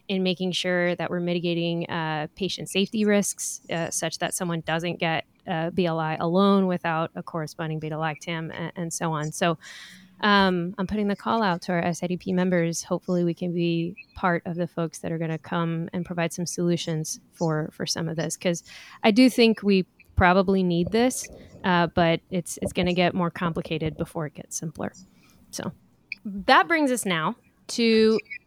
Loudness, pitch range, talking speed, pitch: -25 LUFS, 165-190 Hz, 185 wpm, 175 Hz